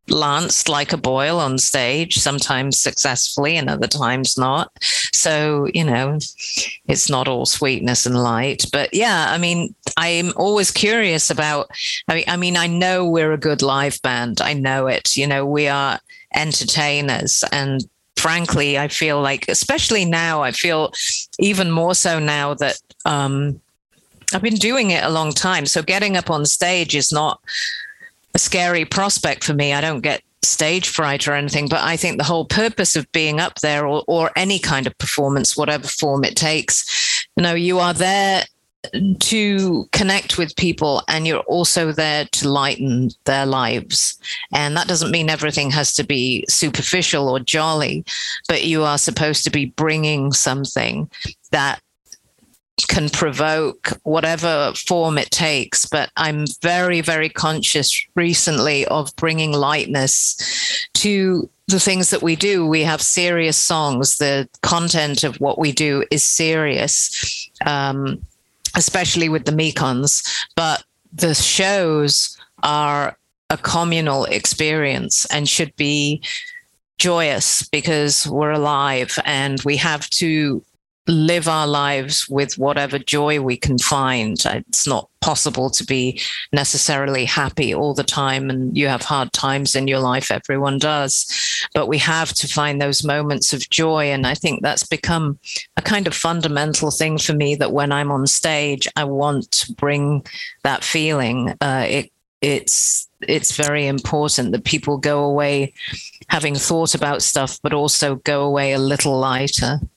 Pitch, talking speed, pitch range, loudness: 150 Hz, 155 wpm, 140-165 Hz, -17 LUFS